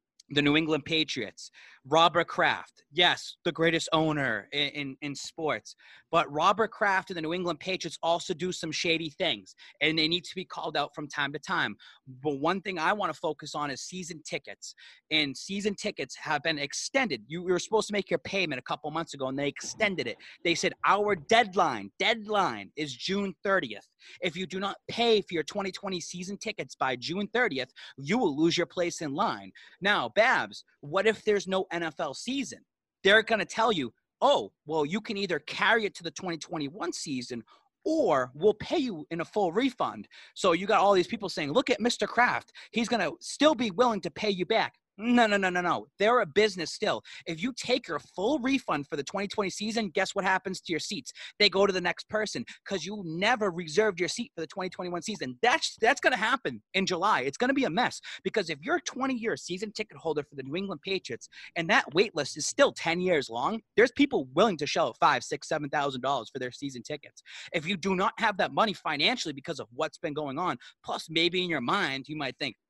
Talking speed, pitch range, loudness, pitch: 220 wpm, 155-215 Hz, -28 LUFS, 180 Hz